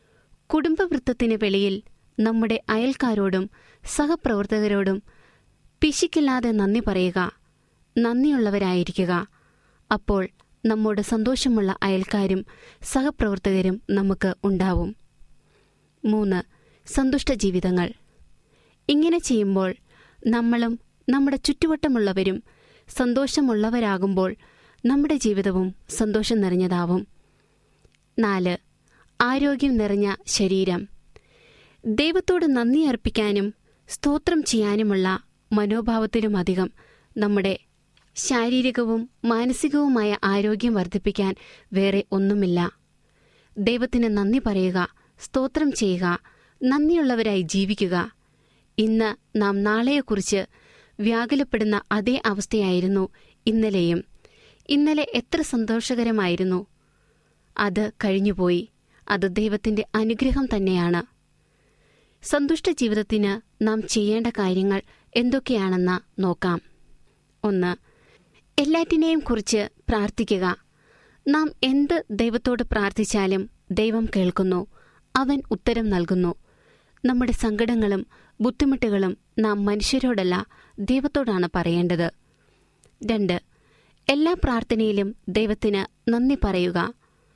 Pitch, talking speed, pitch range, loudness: 215 Hz, 70 wpm, 195-250 Hz, -23 LUFS